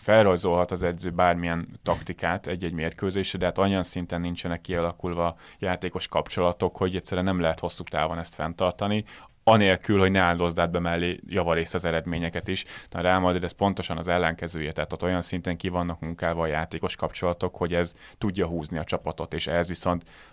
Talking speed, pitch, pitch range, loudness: 170 wpm, 90 Hz, 85-90 Hz, -26 LUFS